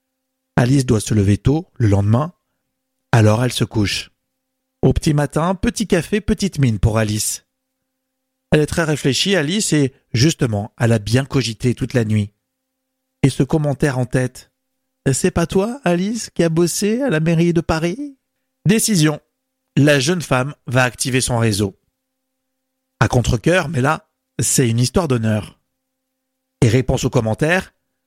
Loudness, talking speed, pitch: -17 LUFS, 150 wpm, 155 Hz